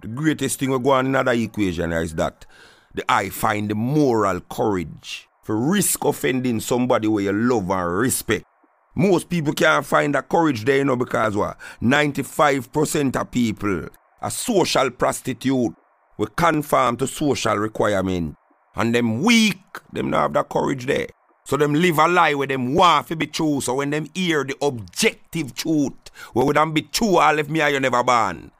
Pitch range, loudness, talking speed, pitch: 115-155 Hz, -20 LUFS, 180 wpm, 135 Hz